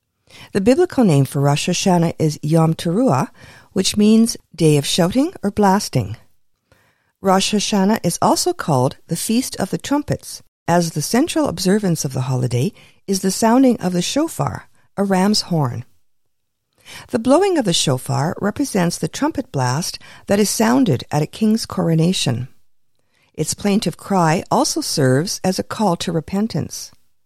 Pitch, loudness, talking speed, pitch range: 175 Hz, -18 LUFS, 150 wpm, 145-210 Hz